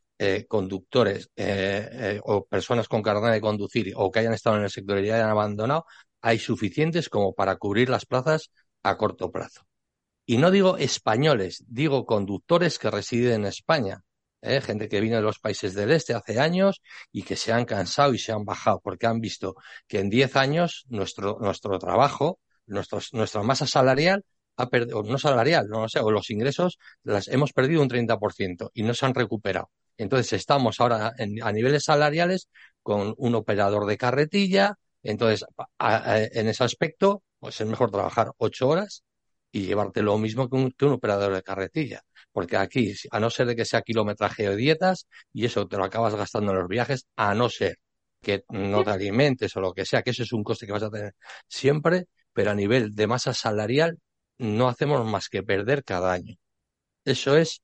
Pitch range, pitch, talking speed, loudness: 105-135 Hz, 115 Hz, 190 wpm, -25 LUFS